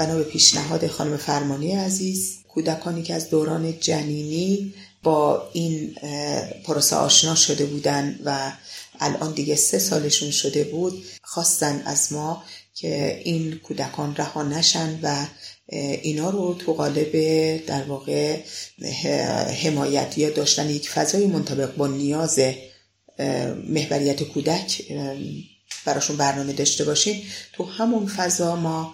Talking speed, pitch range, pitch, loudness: 115 wpm, 145-165 Hz, 150 Hz, -22 LUFS